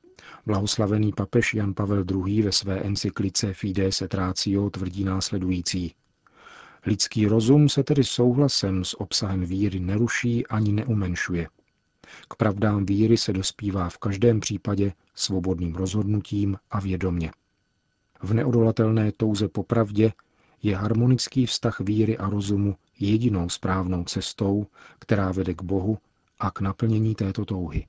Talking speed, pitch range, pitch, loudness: 125 wpm, 95-110 Hz, 100 Hz, -24 LUFS